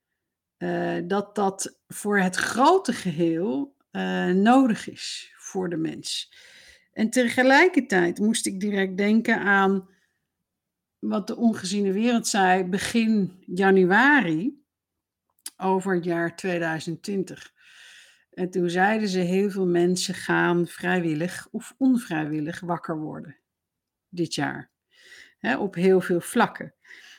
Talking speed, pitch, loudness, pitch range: 115 wpm, 190 Hz, -23 LUFS, 175-220 Hz